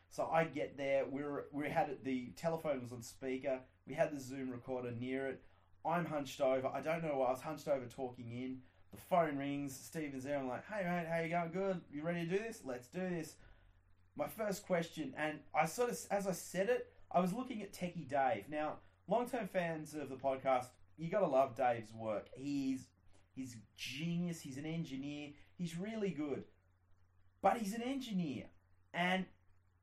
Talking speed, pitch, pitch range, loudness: 195 wpm, 140 Hz, 125-170 Hz, -40 LUFS